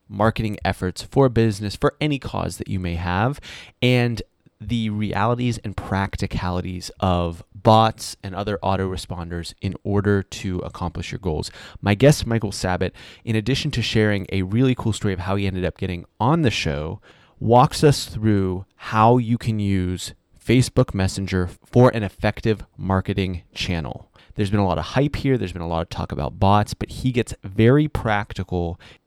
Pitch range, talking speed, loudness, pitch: 95-115 Hz, 170 wpm, -22 LUFS, 105 Hz